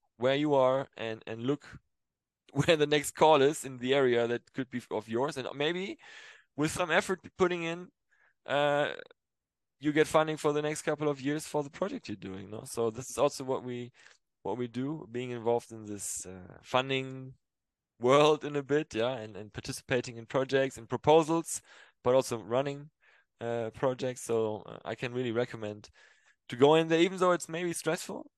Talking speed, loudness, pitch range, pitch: 185 wpm, -30 LUFS, 120-150 Hz, 135 Hz